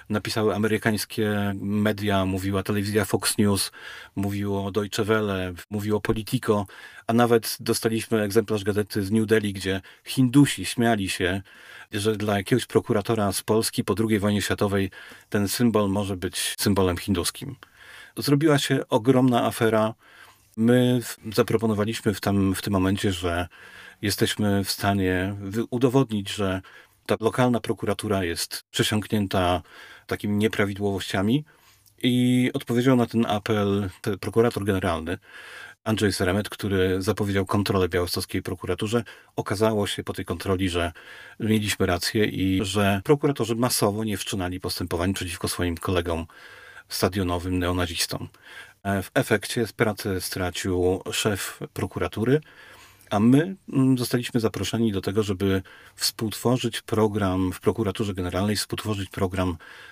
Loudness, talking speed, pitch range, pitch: -24 LUFS, 120 wpm, 95-115 Hz, 105 Hz